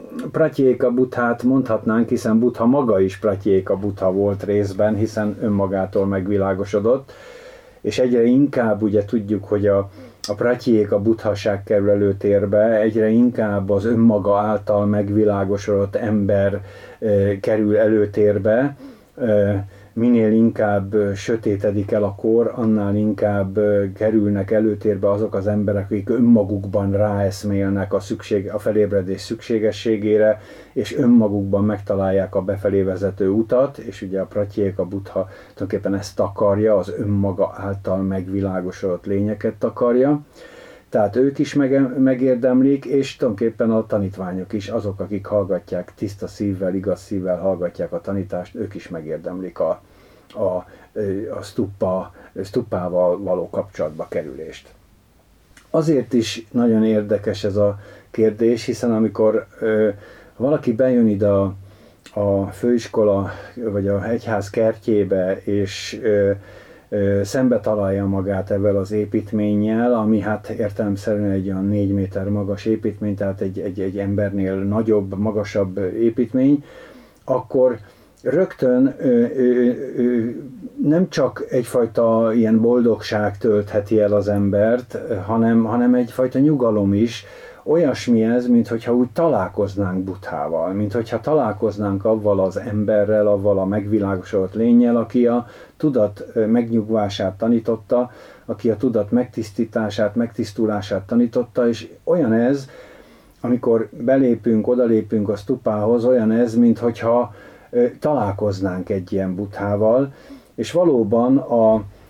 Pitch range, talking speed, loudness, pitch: 100-120 Hz, 120 wpm, -19 LUFS, 105 Hz